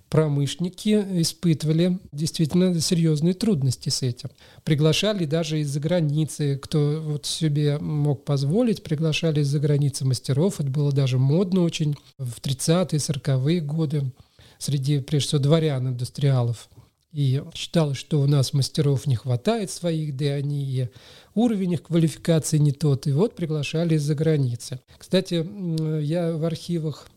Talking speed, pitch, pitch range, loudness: 135 wpm, 150 Hz, 140-165 Hz, -23 LUFS